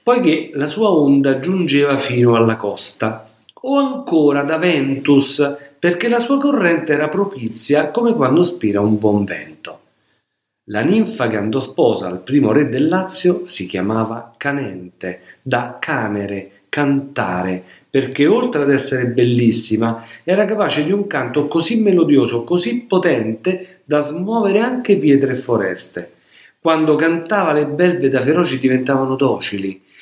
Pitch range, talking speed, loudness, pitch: 115-175 Hz, 135 wpm, -16 LUFS, 140 Hz